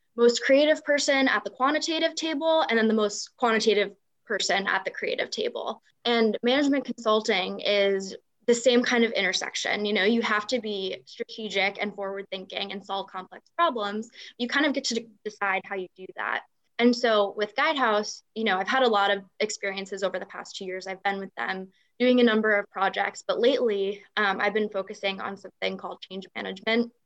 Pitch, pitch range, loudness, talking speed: 215 Hz, 195-250 Hz, -26 LUFS, 195 wpm